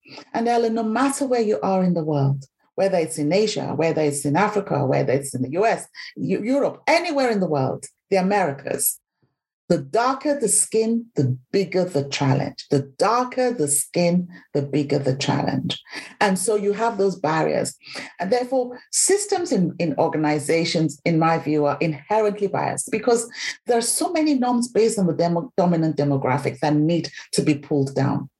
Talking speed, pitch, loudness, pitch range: 175 wpm, 175 Hz, -21 LUFS, 145-230 Hz